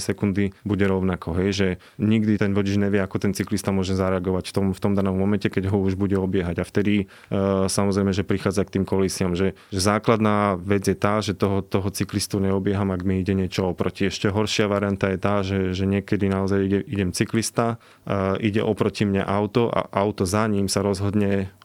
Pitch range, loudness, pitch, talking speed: 95-105 Hz, -23 LUFS, 100 Hz, 200 wpm